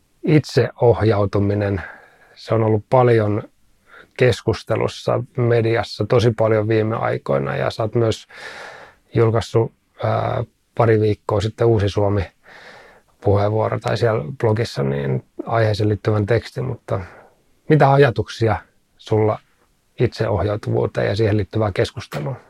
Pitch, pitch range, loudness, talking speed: 110 Hz, 105-115 Hz, -19 LUFS, 100 wpm